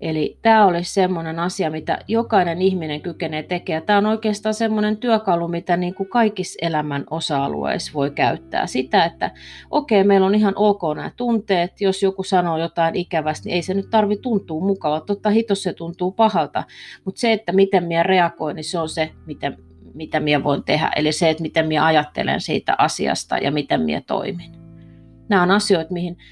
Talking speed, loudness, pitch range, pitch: 180 wpm, -20 LUFS, 160-200 Hz, 180 Hz